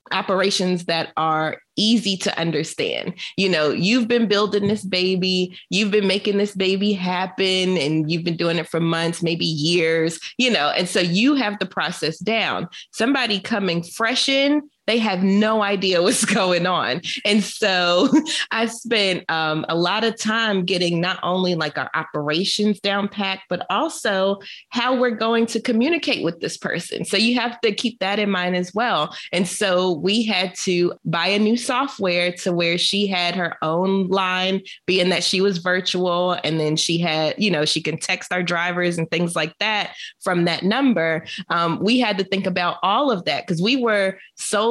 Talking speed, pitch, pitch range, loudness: 185 wpm, 190 Hz, 175-210 Hz, -20 LUFS